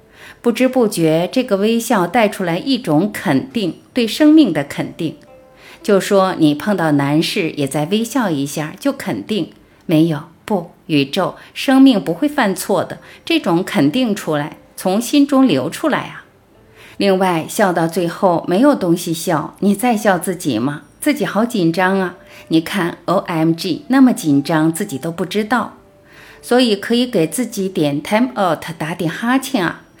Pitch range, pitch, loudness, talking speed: 165-240 Hz, 190 Hz, -16 LUFS, 240 characters per minute